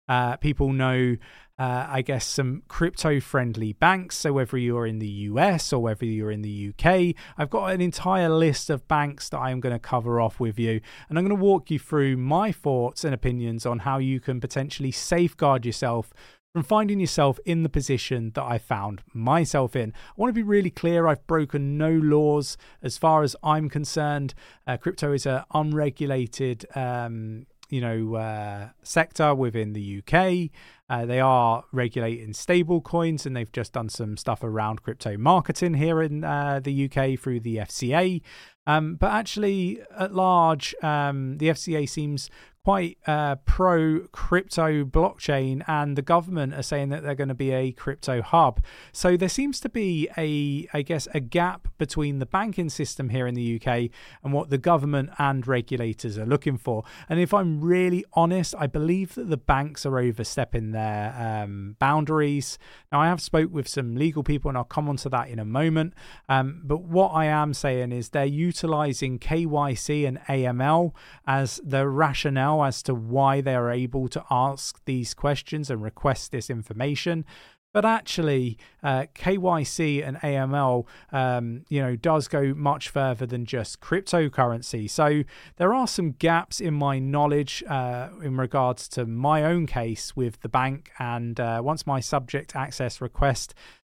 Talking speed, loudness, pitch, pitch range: 175 wpm, -25 LUFS, 140 Hz, 125-160 Hz